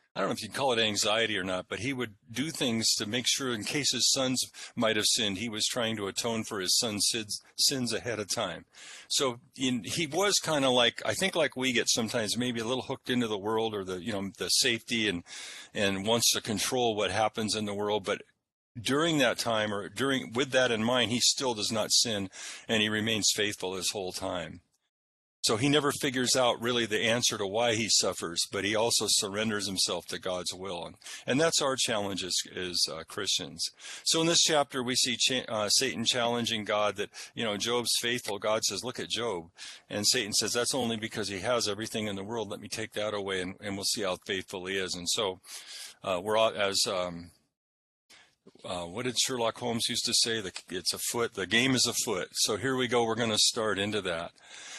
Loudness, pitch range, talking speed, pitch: -28 LUFS, 100-125 Hz, 220 wpm, 115 Hz